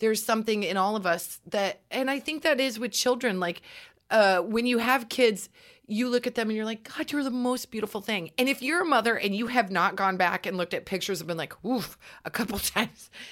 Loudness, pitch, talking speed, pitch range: -27 LUFS, 225 Hz, 250 wpm, 195-255 Hz